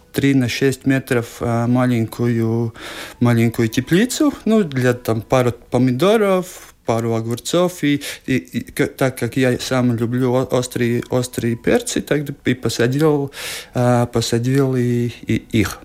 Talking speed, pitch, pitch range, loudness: 130 wpm, 125 Hz, 120-140 Hz, -18 LUFS